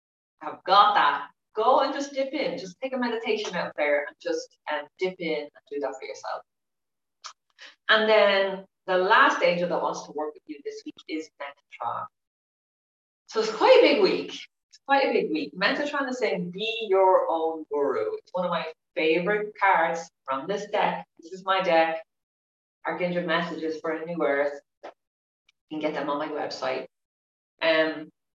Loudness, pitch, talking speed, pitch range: -25 LUFS, 185 Hz, 180 wpm, 160-265 Hz